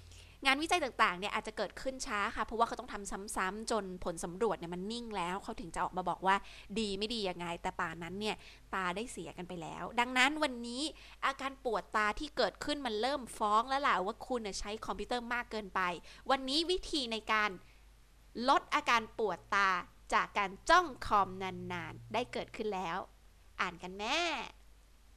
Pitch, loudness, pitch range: 215 Hz, -35 LUFS, 190-250 Hz